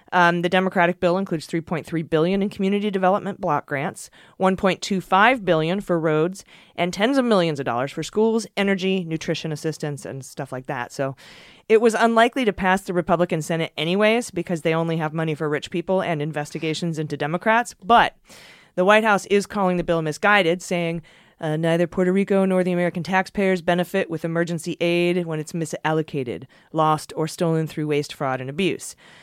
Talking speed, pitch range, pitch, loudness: 175 wpm, 160-190 Hz, 175 Hz, -22 LUFS